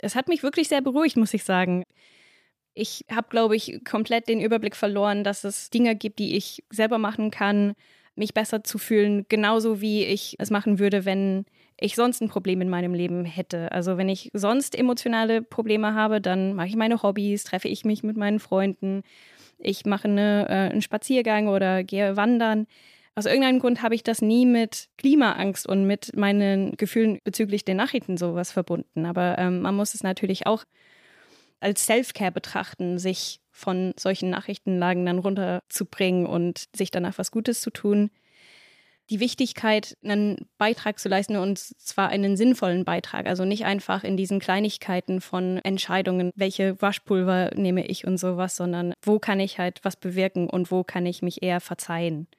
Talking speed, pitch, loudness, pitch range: 175 wpm, 200 Hz, -24 LUFS, 185-220 Hz